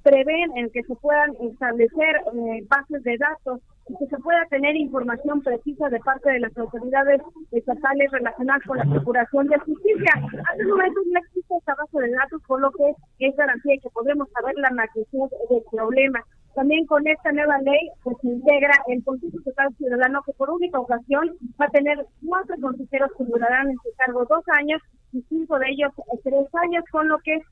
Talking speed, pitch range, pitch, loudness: 195 wpm, 250-300 Hz, 275 Hz, -22 LUFS